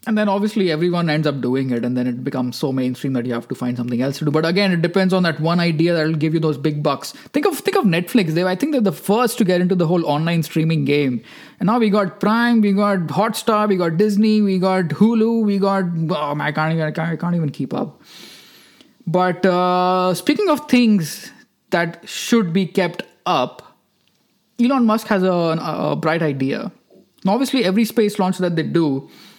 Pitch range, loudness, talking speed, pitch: 155-210 Hz, -18 LUFS, 225 wpm, 180 Hz